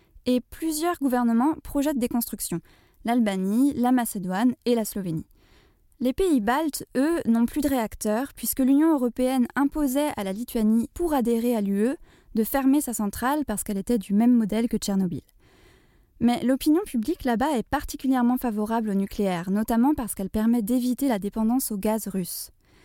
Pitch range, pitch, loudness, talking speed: 215-270 Hz, 240 Hz, -25 LUFS, 165 wpm